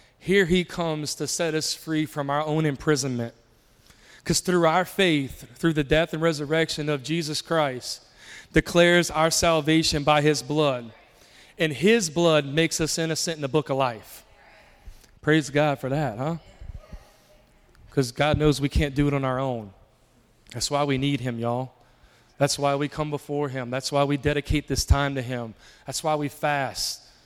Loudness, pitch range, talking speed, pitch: -24 LUFS, 135-160 Hz, 175 wpm, 150 Hz